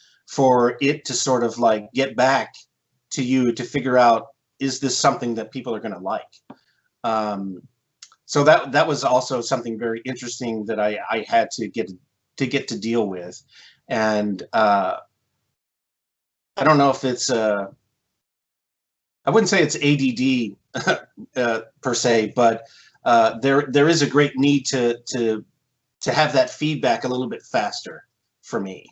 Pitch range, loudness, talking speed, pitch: 115-140 Hz, -21 LUFS, 160 wpm, 125 Hz